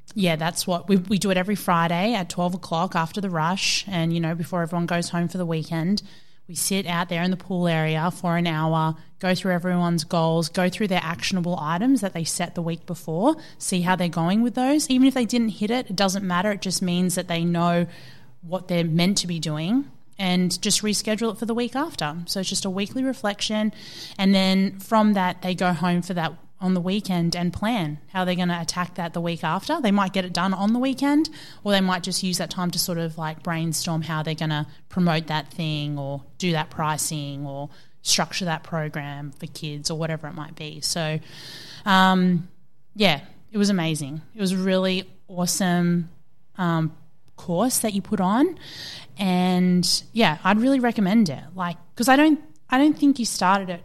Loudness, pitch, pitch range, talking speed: -23 LUFS, 180 Hz, 165-195 Hz, 210 wpm